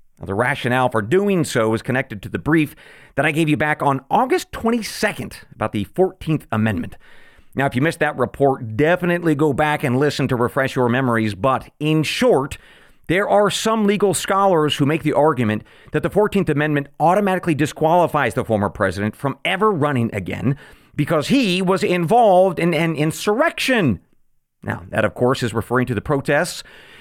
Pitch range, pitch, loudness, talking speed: 120-170 Hz, 145 Hz, -19 LUFS, 175 wpm